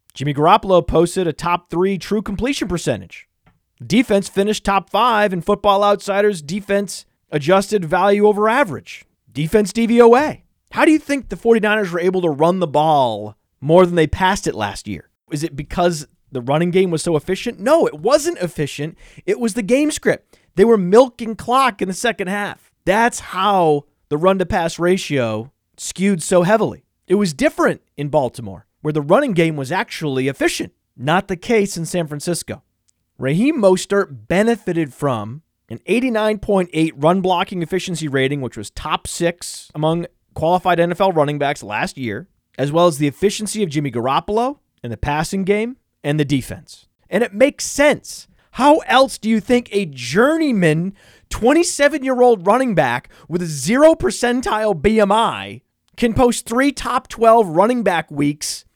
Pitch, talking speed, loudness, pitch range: 185 Hz, 165 wpm, -17 LUFS, 150-220 Hz